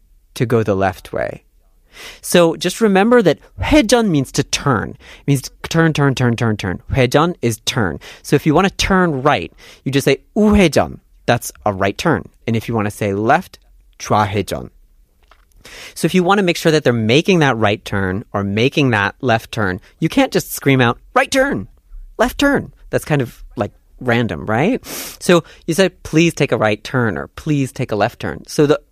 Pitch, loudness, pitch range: 140 Hz, -16 LUFS, 110-175 Hz